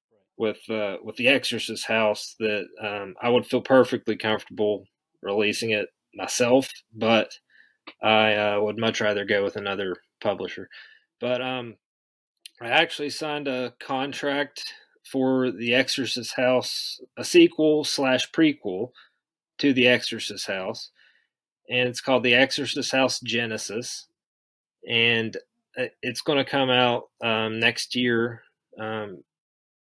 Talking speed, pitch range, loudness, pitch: 125 wpm, 110-135 Hz, -24 LUFS, 125 Hz